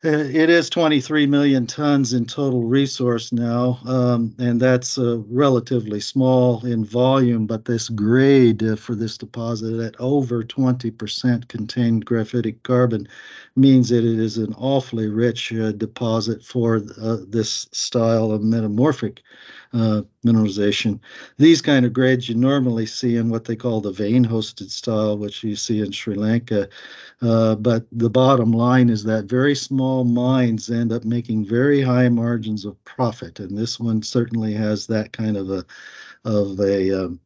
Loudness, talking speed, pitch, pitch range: -20 LUFS, 155 wpm, 115 Hz, 110-125 Hz